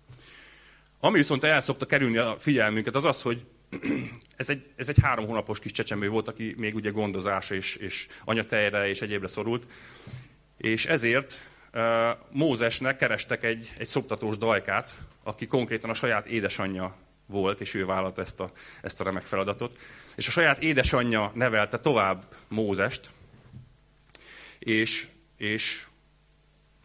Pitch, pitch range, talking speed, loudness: 115 Hz, 105-130 Hz, 135 wpm, -27 LUFS